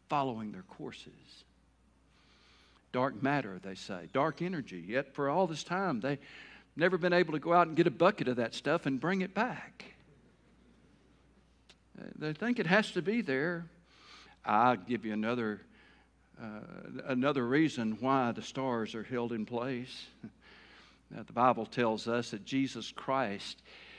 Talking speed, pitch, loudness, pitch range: 155 wpm, 135 Hz, -33 LUFS, 115-170 Hz